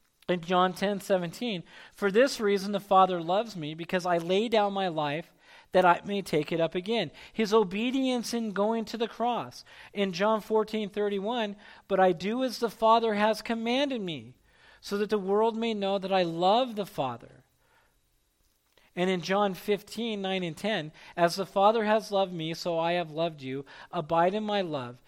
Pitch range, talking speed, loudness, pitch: 175-220 Hz, 175 wpm, -28 LUFS, 195 Hz